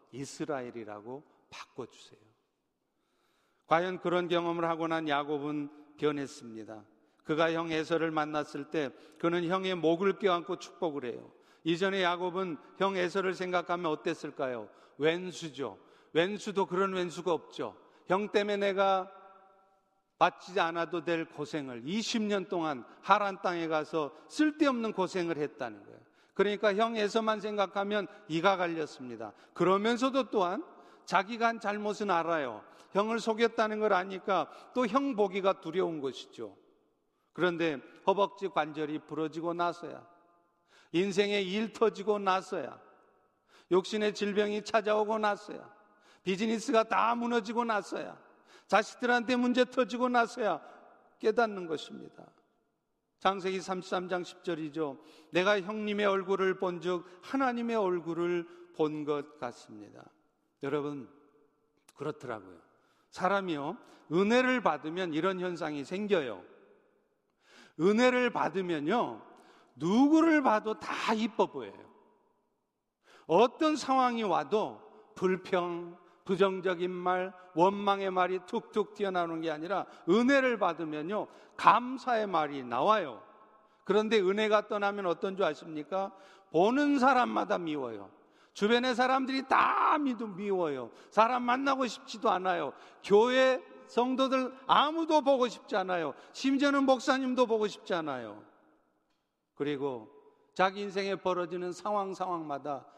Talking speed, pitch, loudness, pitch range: 270 characters per minute, 190 Hz, -31 LUFS, 165-215 Hz